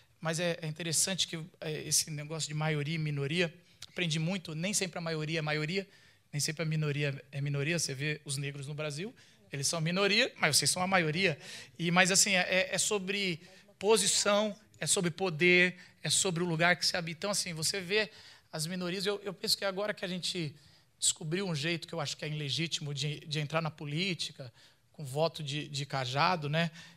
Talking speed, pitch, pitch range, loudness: 200 wpm, 165 Hz, 150-185 Hz, -31 LUFS